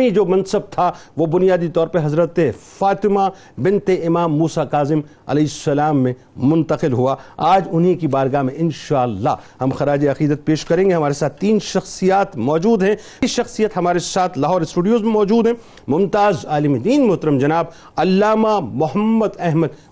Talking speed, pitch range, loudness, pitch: 160 wpm, 150-195 Hz, -17 LUFS, 170 Hz